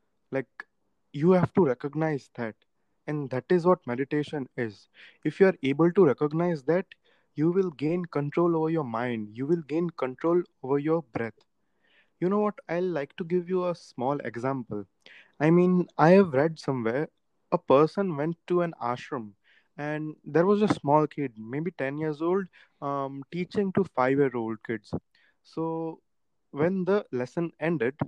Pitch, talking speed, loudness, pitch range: 155 Hz, 165 wpm, -27 LUFS, 135-175 Hz